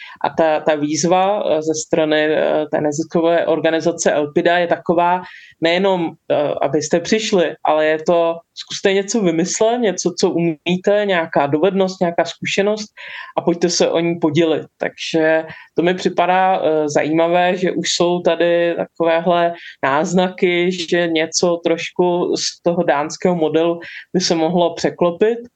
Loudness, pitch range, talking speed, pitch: -17 LUFS, 160-180 Hz, 130 wpm, 170 Hz